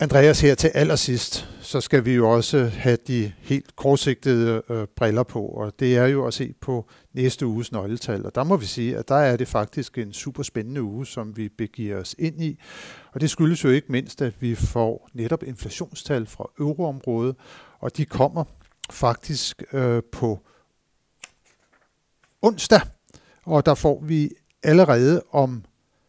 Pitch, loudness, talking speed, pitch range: 130 Hz, -22 LUFS, 165 wpm, 115-145 Hz